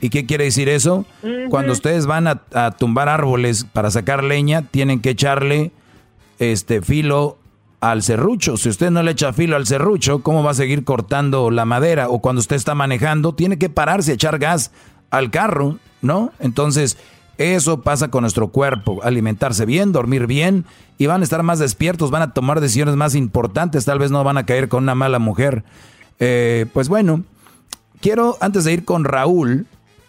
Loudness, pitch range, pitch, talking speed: -17 LUFS, 125-155 Hz, 140 Hz, 185 wpm